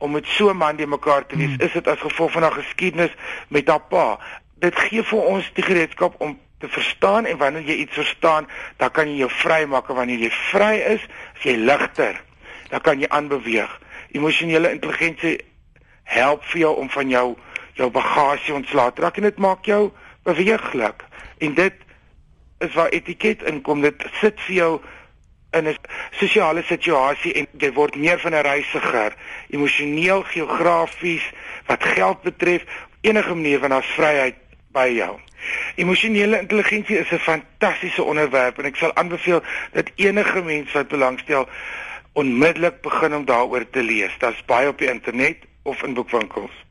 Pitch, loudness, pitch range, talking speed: 160 Hz, -19 LUFS, 145-175 Hz, 170 wpm